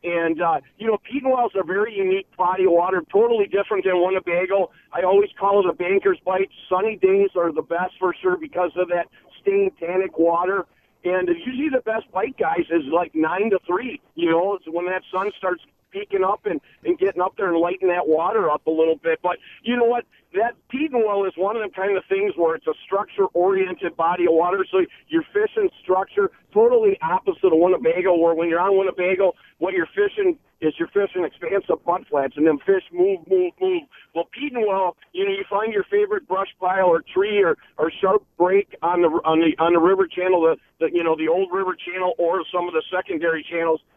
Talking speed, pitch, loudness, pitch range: 220 wpm, 190 Hz, -21 LUFS, 175-245 Hz